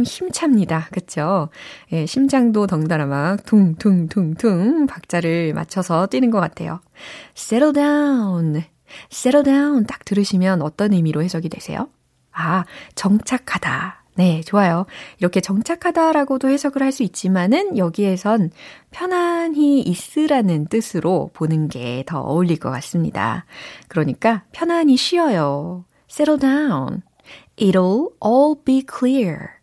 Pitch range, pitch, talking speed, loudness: 170-270 Hz, 205 Hz, 310 characters per minute, -18 LUFS